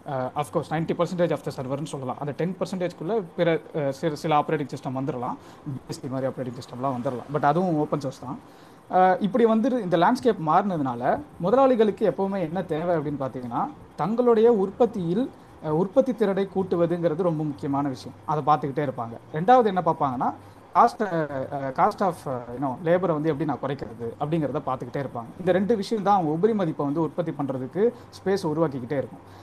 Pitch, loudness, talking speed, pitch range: 155 Hz, -25 LUFS, 155 wpm, 140-185 Hz